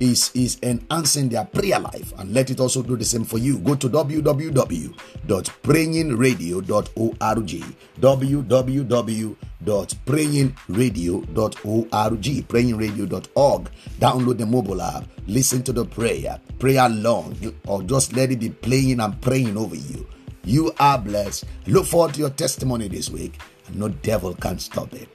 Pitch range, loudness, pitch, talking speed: 110-130 Hz, -21 LUFS, 125 Hz, 135 wpm